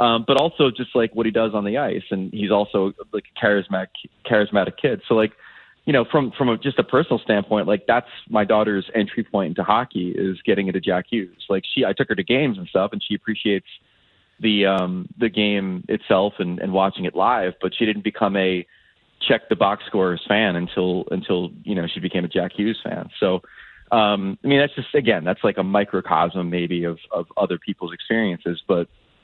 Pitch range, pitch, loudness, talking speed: 95-115 Hz, 105 Hz, -21 LUFS, 210 wpm